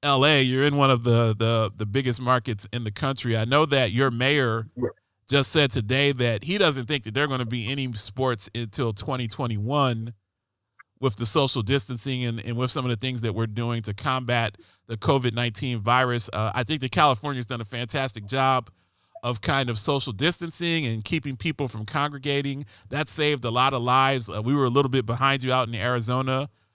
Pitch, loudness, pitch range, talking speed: 125 Hz, -24 LUFS, 115-140 Hz, 205 wpm